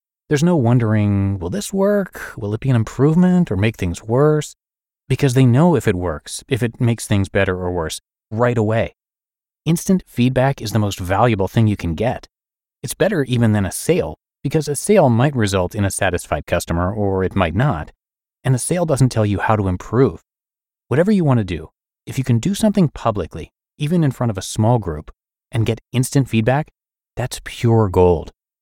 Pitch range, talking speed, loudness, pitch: 100-140 Hz, 195 wpm, -18 LUFS, 115 Hz